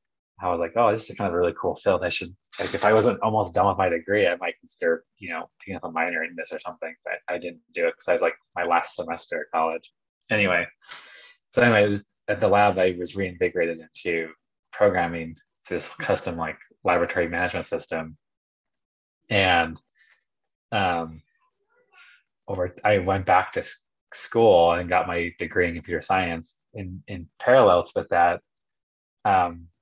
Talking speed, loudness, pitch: 175 wpm, -24 LUFS, 90 Hz